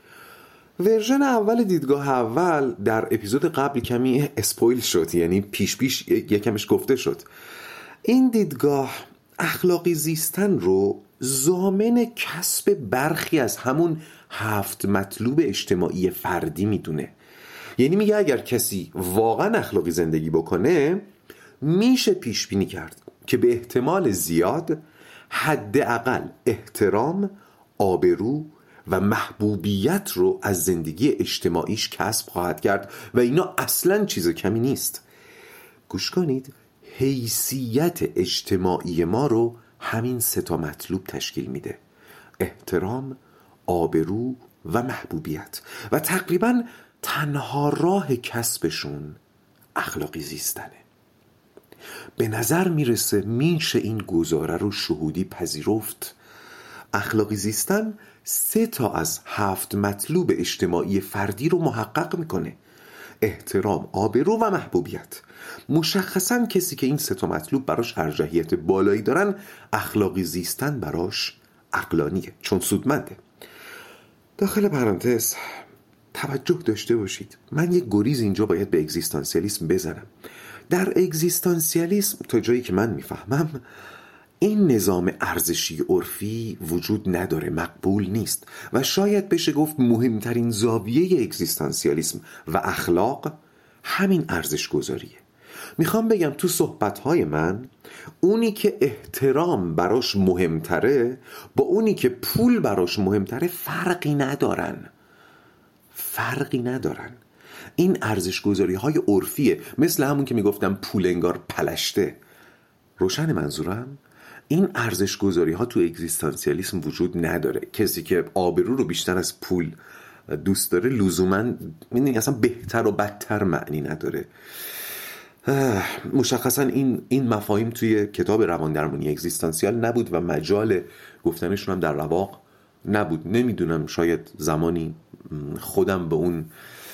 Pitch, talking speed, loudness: 125 Hz, 110 wpm, -23 LUFS